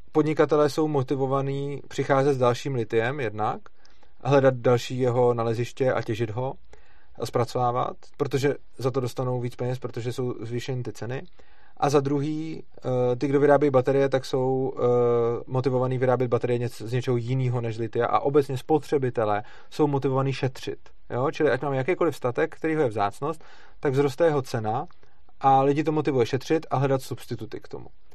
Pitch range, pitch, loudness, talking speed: 125-140 Hz, 130 Hz, -25 LUFS, 160 wpm